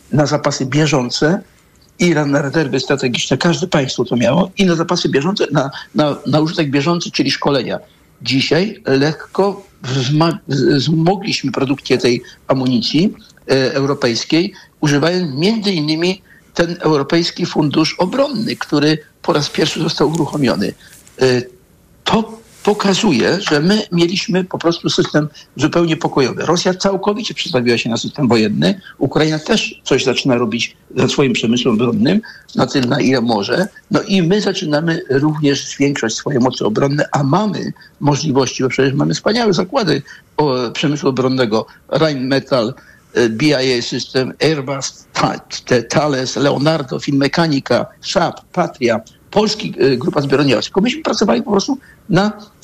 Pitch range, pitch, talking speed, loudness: 135-185 Hz, 155 Hz, 130 wpm, -16 LUFS